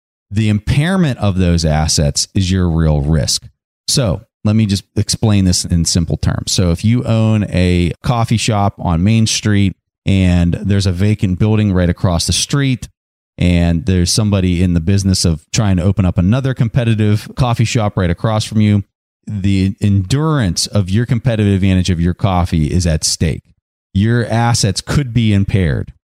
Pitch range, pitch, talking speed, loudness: 90-110 Hz, 100 Hz, 170 wpm, -14 LUFS